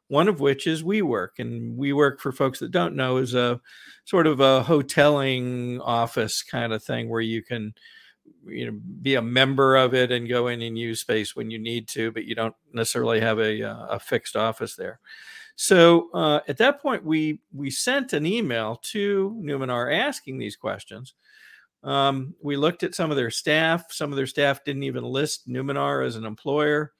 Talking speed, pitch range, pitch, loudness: 195 wpm, 115-155 Hz, 135 Hz, -24 LUFS